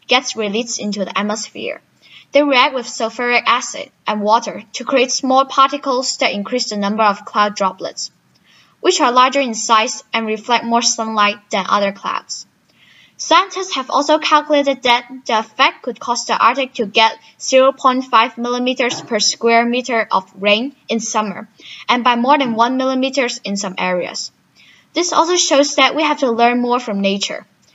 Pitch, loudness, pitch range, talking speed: 245 Hz, -16 LUFS, 220-270 Hz, 165 wpm